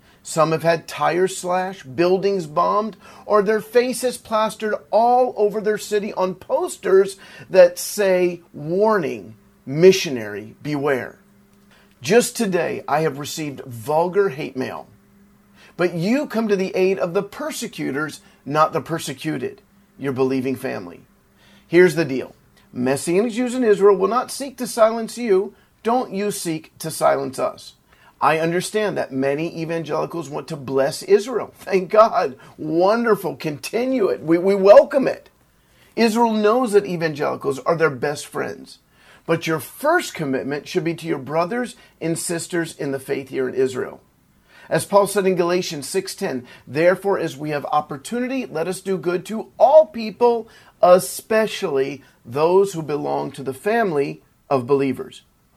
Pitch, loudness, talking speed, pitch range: 185 Hz, -20 LUFS, 145 wpm, 155-215 Hz